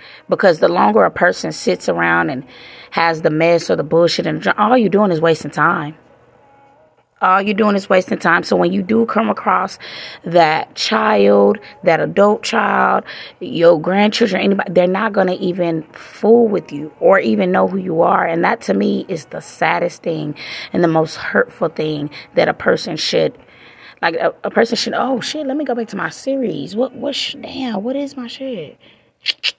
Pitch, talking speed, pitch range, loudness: 185 Hz, 190 wpm, 160-235 Hz, -16 LUFS